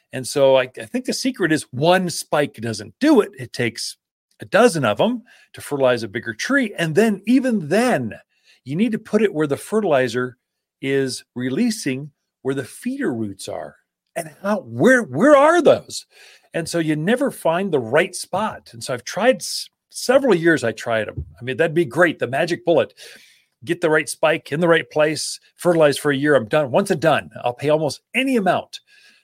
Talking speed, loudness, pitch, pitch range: 195 wpm, -19 LUFS, 165 Hz, 135-225 Hz